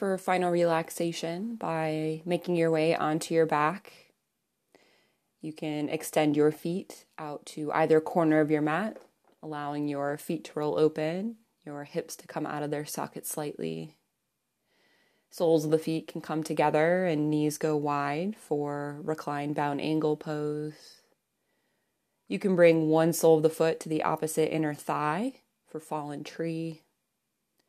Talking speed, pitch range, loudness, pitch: 150 wpm, 150-165 Hz, -29 LUFS, 155 Hz